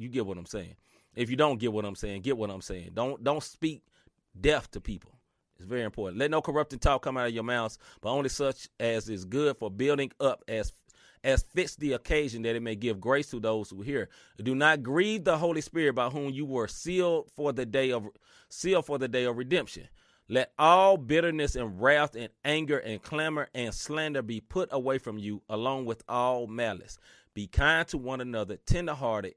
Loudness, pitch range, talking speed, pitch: -29 LUFS, 110-145 Hz, 210 wpm, 130 Hz